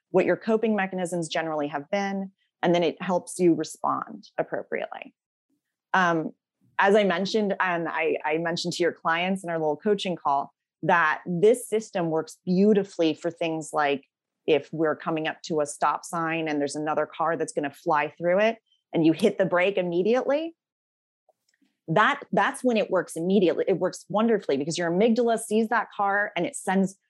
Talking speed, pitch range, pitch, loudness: 175 wpm, 160-205 Hz, 175 Hz, -25 LUFS